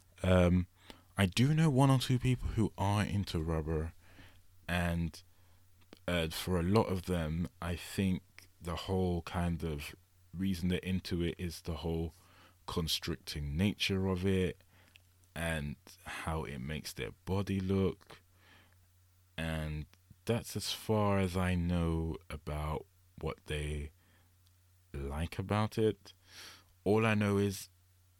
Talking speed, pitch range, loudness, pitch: 130 wpm, 85-95 Hz, -35 LUFS, 90 Hz